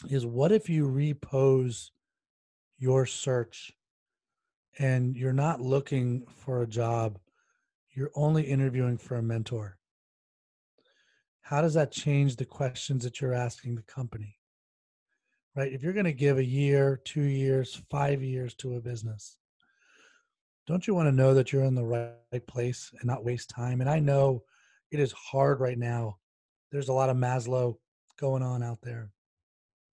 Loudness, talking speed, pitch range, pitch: -29 LUFS, 155 wpm, 120-140 Hz, 130 Hz